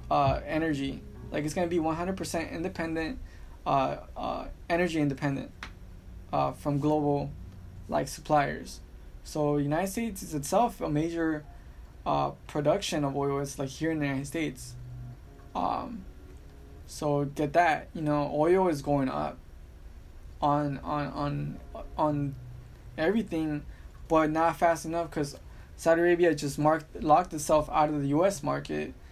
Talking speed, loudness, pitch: 140 wpm, -29 LUFS, 145 Hz